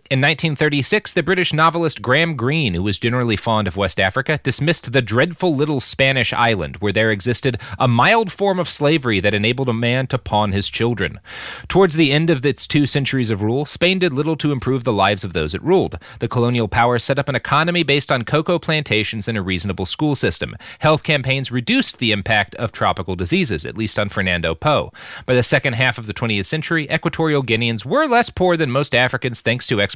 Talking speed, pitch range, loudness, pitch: 210 wpm, 110-155 Hz, -17 LUFS, 130 Hz